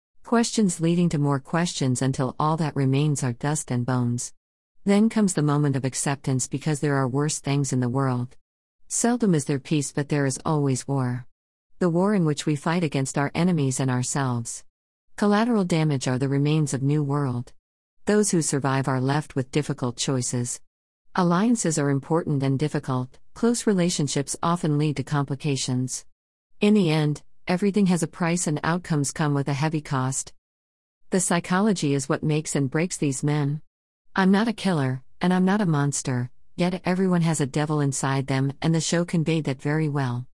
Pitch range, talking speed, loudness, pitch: 135-165 Hz, 180 wpm, -24 LUFS, 145 Hz